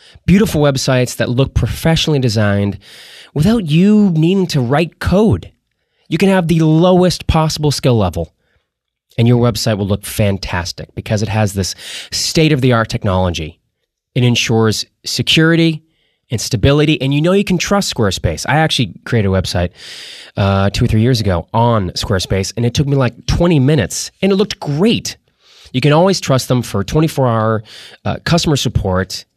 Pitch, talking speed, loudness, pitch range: 125 Hz, 170 wpm, -14 LUFS, 105-155 Hz